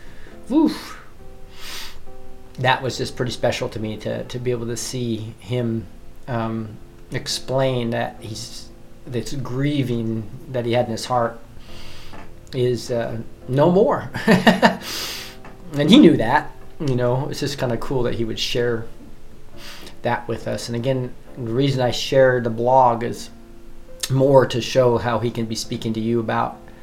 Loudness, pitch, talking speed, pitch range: -21 LUFS, 115 Hz, 155 wpm, 110-125 Hz